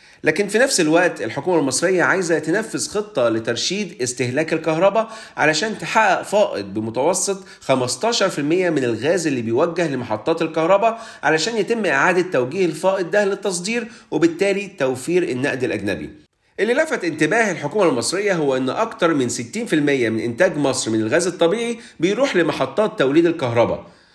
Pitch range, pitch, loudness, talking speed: 140-205 Hz, 170 Hz, -19 LUFS, 135 wpm